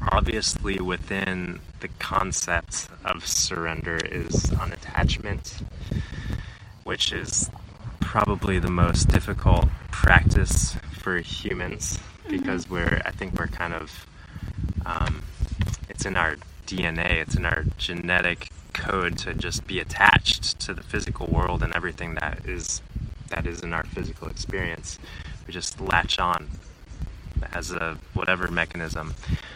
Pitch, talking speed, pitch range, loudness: 85 Hz, 125 wpm, 80-95 Hz, -25 LUFS